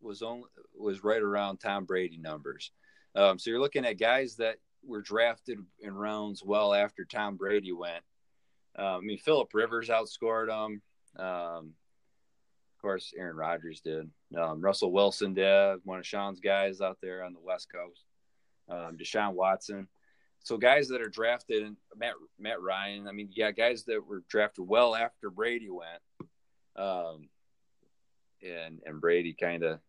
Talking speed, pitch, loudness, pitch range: 160 wpm, 100 Hz, -31 LUFS, 85-105 Hz